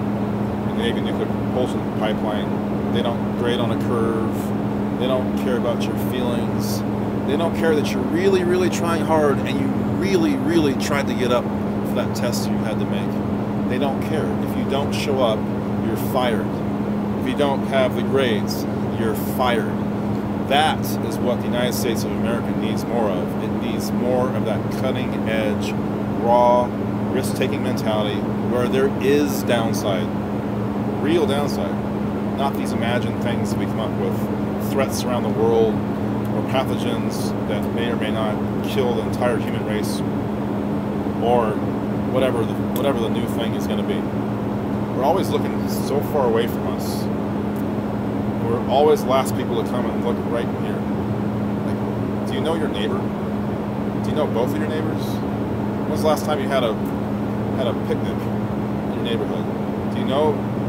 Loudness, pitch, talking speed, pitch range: -21 LUFS, 105 Hz, 165 wpm, 100-105 Hz